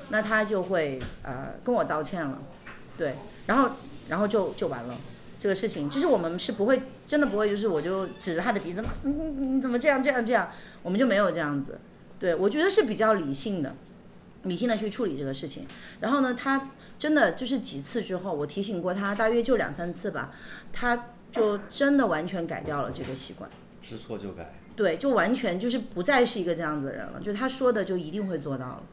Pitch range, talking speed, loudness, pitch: 180-255 Hz, 315 characters per minute, -27 LUFS, 215 Hz